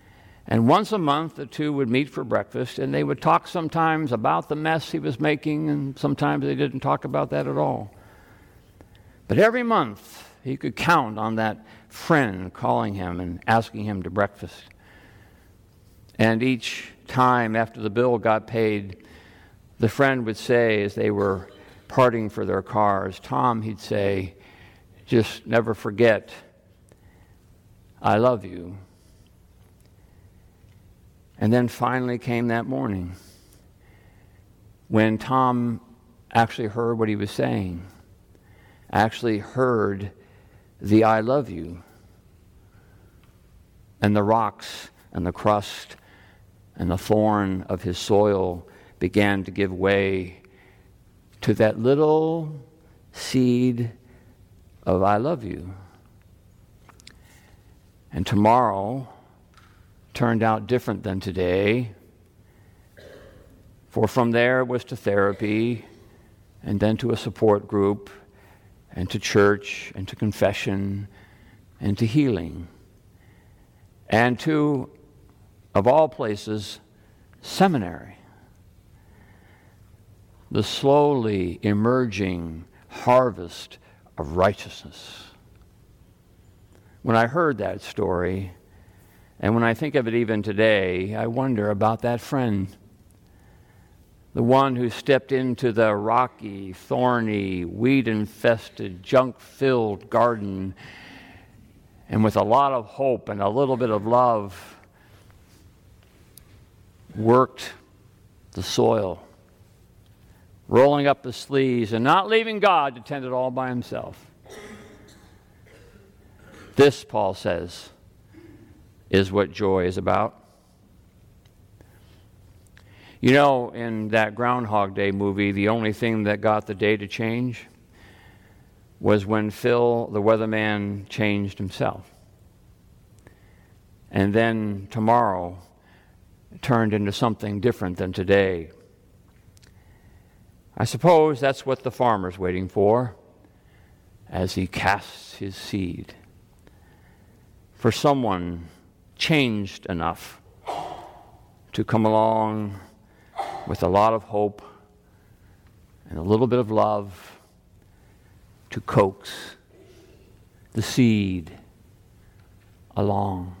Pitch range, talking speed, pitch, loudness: 95-115 Hz, 110 wpm, 105 Hz, -23 LUFS